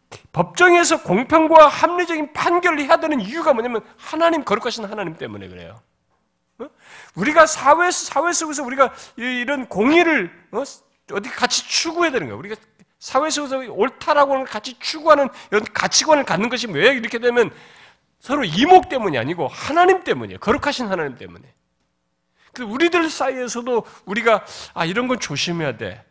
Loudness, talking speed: -18 LUFS, 365 characters per minute